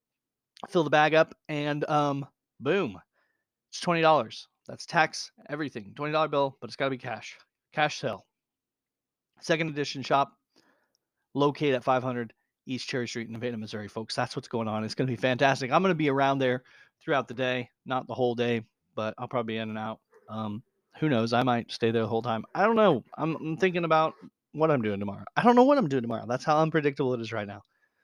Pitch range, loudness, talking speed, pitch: 115-150 Hz, -28 LUFS, 210 wpm, 130 Hz